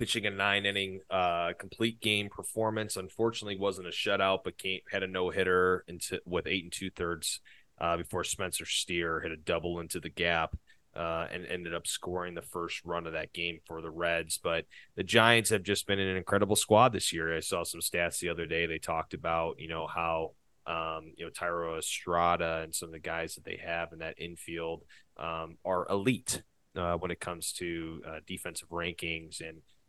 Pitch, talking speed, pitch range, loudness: 85 Hz, 195 wpm, 85-100 Hz, -32 LUFS